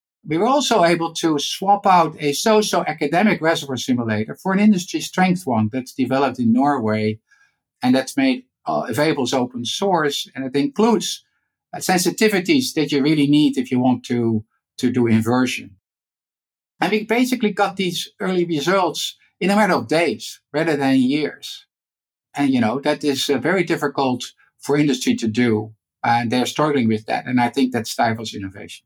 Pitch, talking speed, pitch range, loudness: 145 Hz, 175 wpm, 125-185 Hz, -19 LUFS